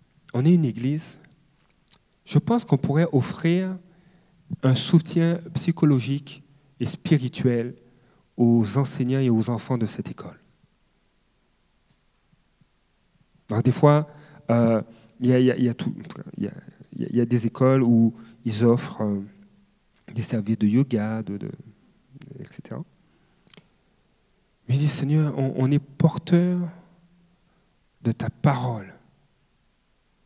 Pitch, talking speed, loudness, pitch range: 140 Hz, 120 wpm, -23 LUFS, 120-170 Hz